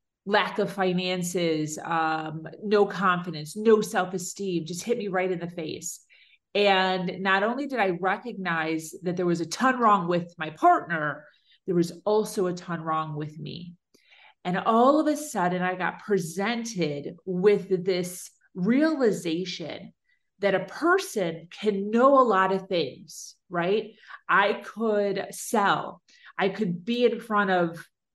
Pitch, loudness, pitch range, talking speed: 190 Hz, -26 LUFS, 175-210 Hz, 145 wpm